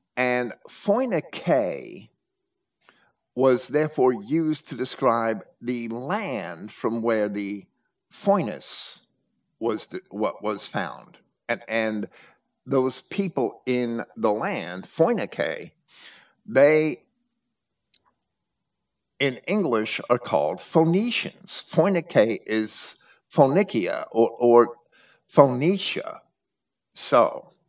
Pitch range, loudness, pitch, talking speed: 115-180 Hz, -24 LUFS, 130 Hz, 85 wpm